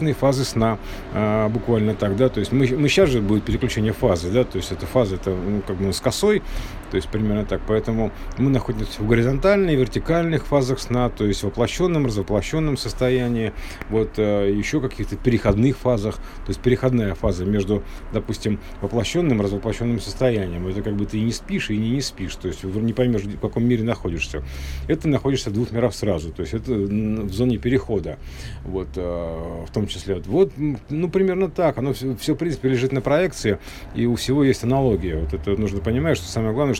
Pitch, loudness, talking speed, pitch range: 110 Hz, -22 LUFS, 195 wpm, 100-130 Hz